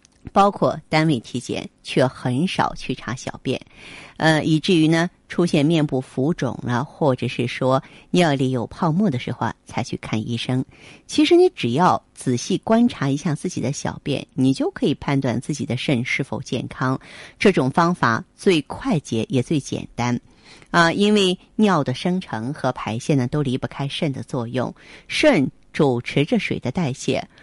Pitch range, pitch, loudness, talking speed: 125-170 Hz, 140 Hz, -21 LUFS, 245 characters per minute